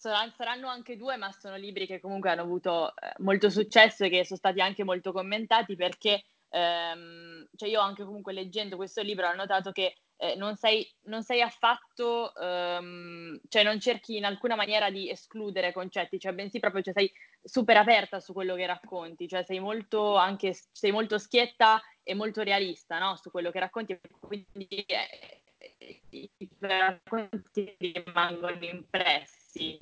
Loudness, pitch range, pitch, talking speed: -29 LUFS, 185-215 Hz, 195 Hz, 160 wpm